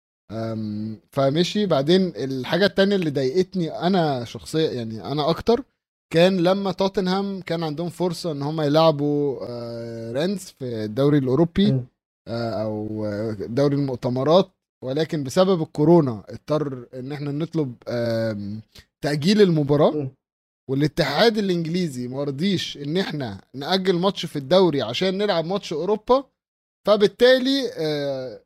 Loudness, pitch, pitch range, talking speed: -22 LUFS, 150 Hz, 130-185 Hz, 120 wpm